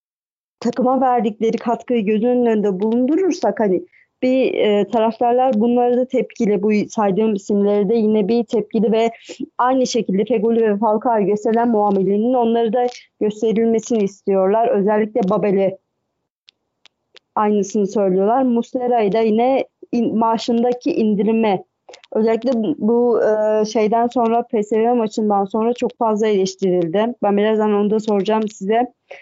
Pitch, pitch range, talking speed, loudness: 225 Hz, 210-240 Hz, 125 wpm, -17 LUFS